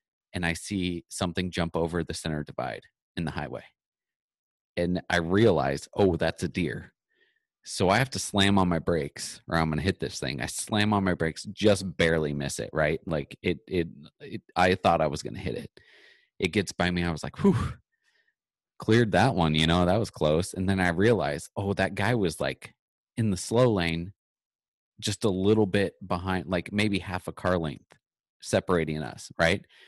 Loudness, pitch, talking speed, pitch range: -27 LUFS, 90 Hz, 195 wpm, 80-100 Hz